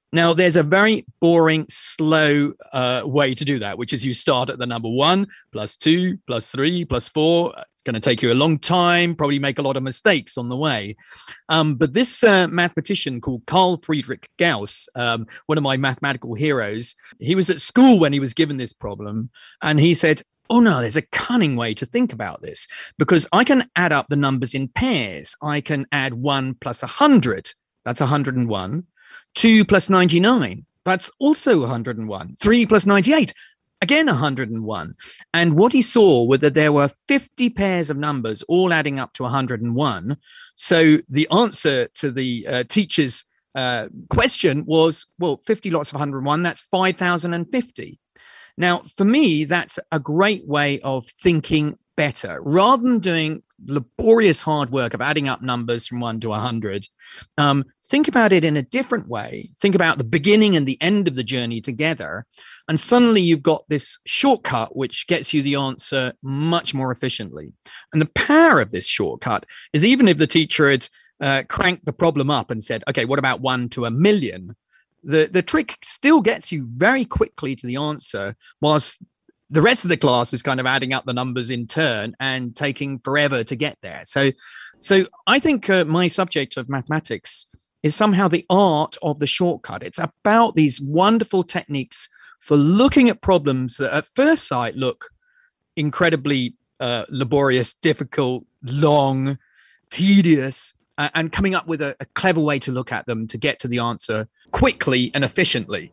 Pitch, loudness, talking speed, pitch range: 150 Hz, -19 LUFS, 180 wpm, 130-185 Hz